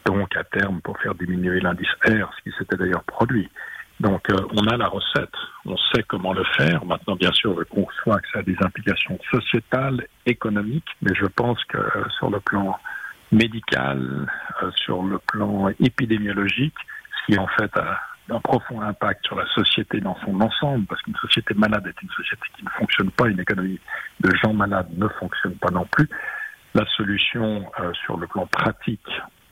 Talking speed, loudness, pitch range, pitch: 185 wpm, -22 LUFS, 95-120 Hz, 105 Hz